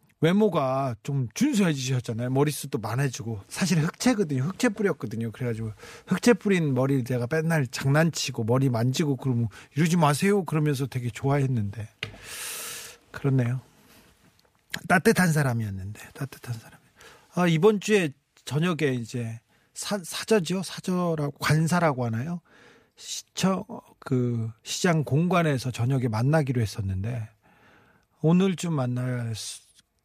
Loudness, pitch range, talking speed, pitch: -26 LUFS, 120-175 Hz, 300 characters per minute, 145 Hz